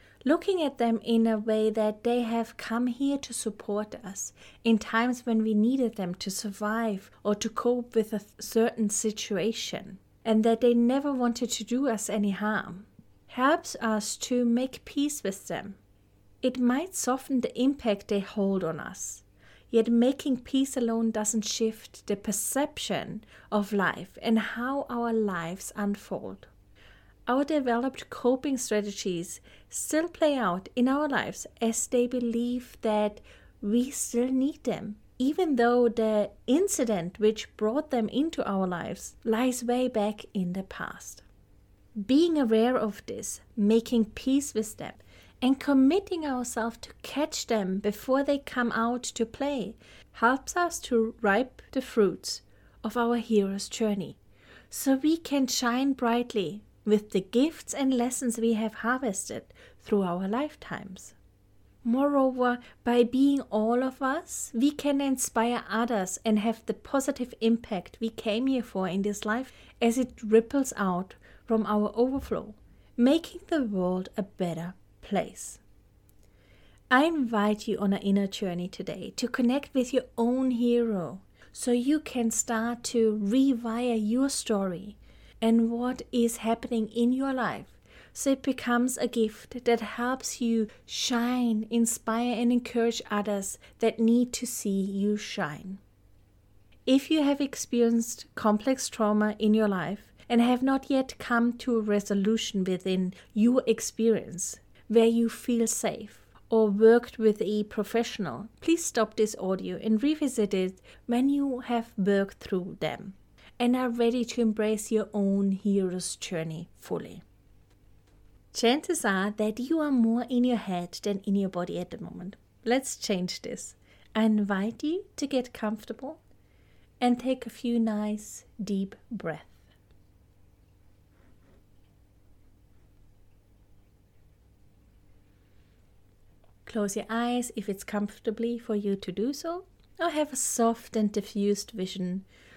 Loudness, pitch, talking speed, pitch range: -28 LUFS, 225 Hz, 140 wpm, 200-245 Hz